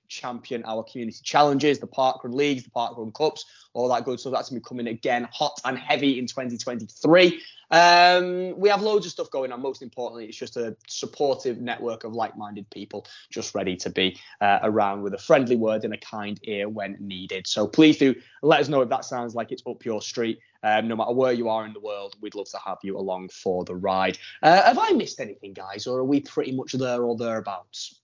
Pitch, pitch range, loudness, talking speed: 120 Hz, 105-135 Hz, -24 LUFS, 225 wpm